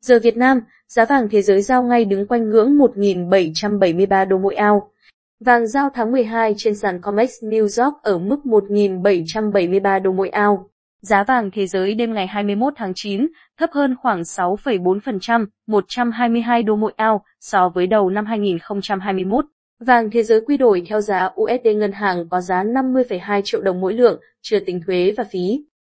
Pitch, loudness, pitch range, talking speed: 210 Hz, -18 LUFS, 195-235 Hz, 175 wpm